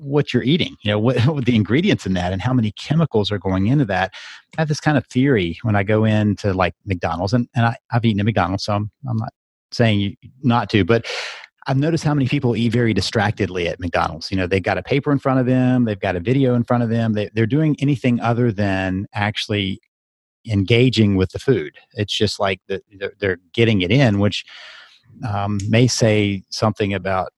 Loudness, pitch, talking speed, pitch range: -19 LUFS, 110 Hz, 215 wpm, 100-125 Hz